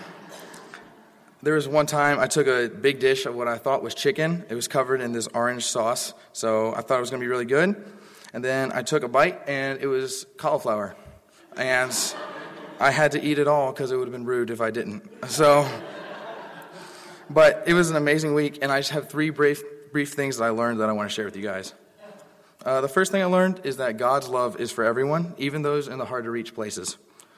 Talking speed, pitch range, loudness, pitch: 225 wpm, 125-155 Hz, -24 LUFS, 140 Hz